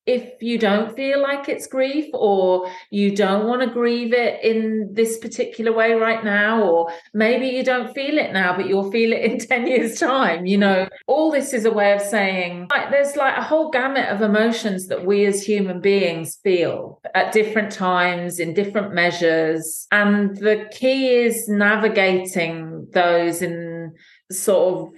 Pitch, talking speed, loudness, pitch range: 210 Hz, 175 wpm, -19 LUFS, 185-240 Hz